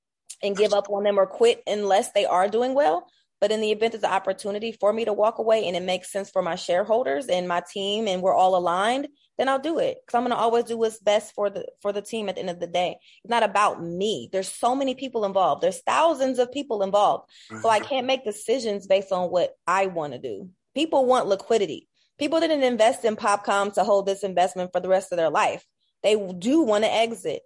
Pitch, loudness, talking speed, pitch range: 210 Hz, -24 LUFS, 240 wpm, 190-240 Hz